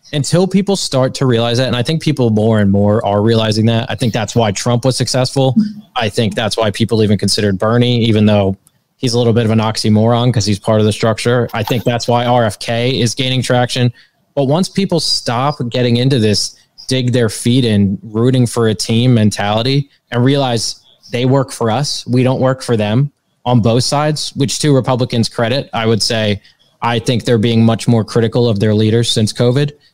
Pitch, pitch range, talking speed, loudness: 120 Hz, 110-130 Hz, 205 wpm, -14 LUFS